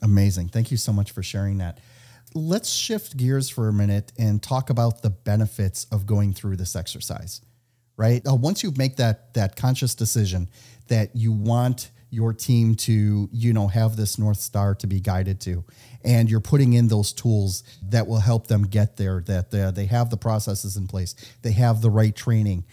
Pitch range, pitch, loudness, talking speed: 100-120 Hz, 110 Hz, -23 LUFS, 190 wpm